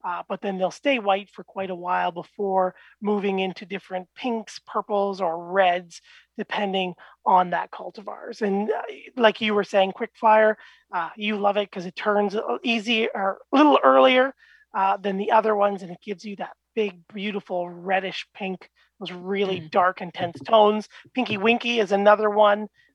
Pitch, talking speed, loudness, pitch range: 200 Hz, 170 wpm, -23 LUFS, 185-215 Hz